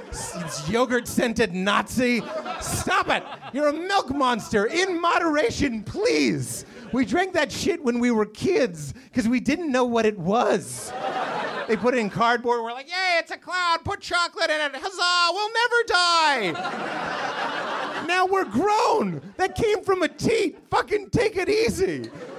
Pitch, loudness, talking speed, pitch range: 310 Hz, -23 LUFS, 155 wpm, 240-375 Hz